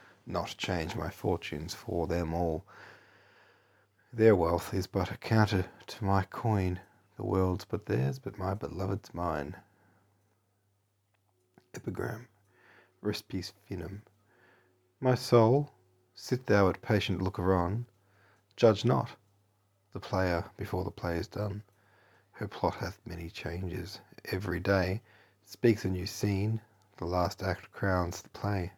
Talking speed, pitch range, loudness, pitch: 125 wpm, 90-105 Hz, -32 LUFS, 100 Hz